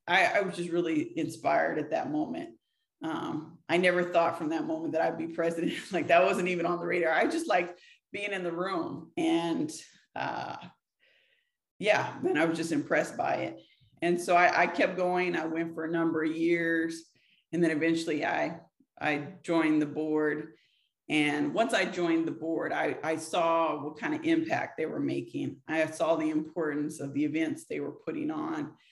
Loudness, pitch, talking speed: -30 LUFS, 170 Hz, 190 wpm